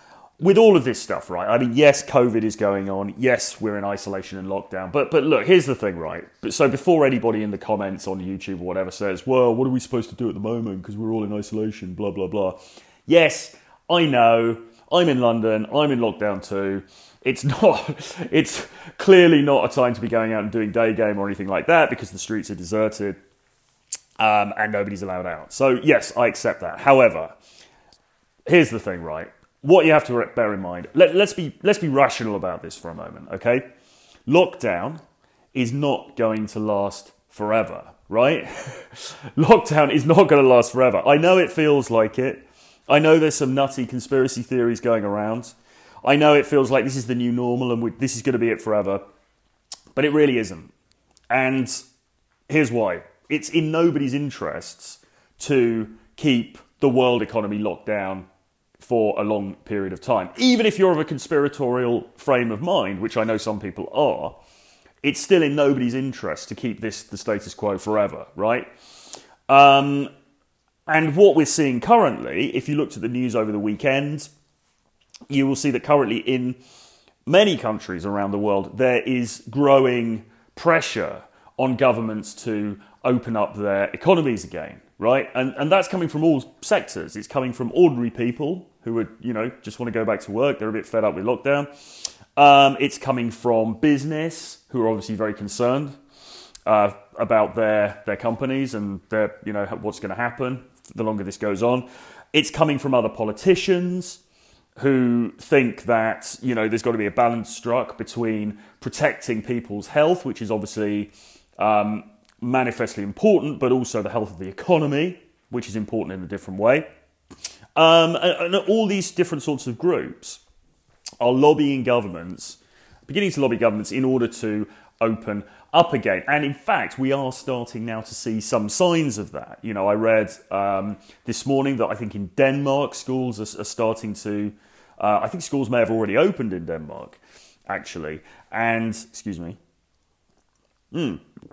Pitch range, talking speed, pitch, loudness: 105-140 Hz, 180 wpm, 120 Hz, -21 LUFS